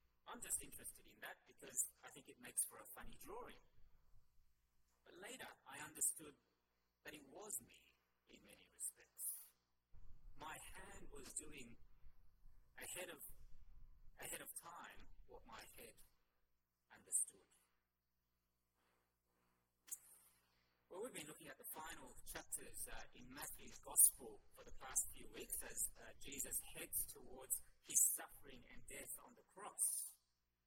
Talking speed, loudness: 130 wpm, -44 LUFS